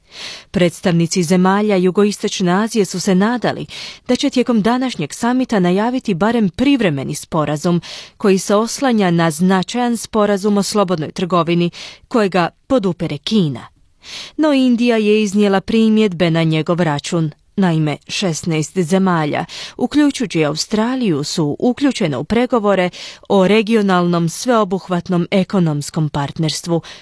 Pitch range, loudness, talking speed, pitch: 170-220 Hz, -16 LUFS, 110 wpm, 190 Hz